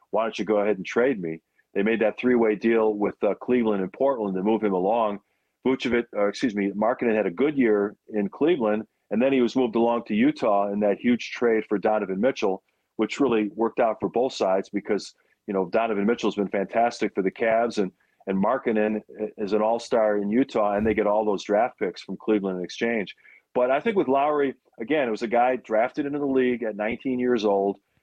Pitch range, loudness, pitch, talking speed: 100-120 Hz, -24 LUFS, 110 Hz, 225 wpm